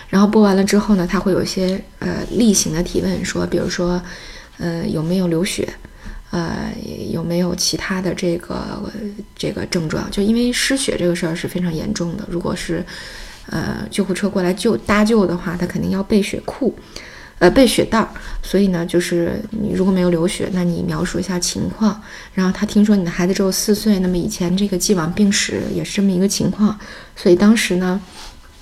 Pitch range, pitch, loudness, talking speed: 175-205 Hz, 185 Hz, -18 LUFS, 290 characters per minute